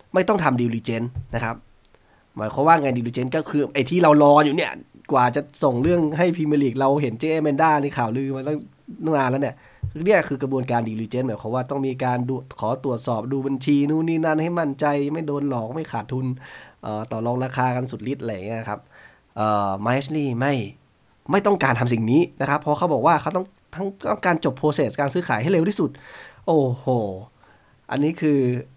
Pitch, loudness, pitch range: 135 Hz, -22 LUFS, 120-150 Hz